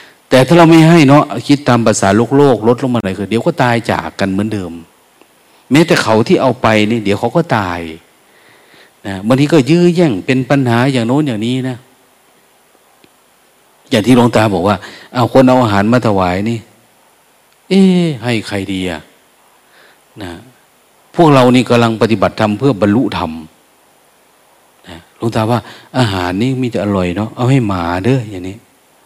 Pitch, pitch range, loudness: 120 Hz, 100-130 Hz, -12 LUFS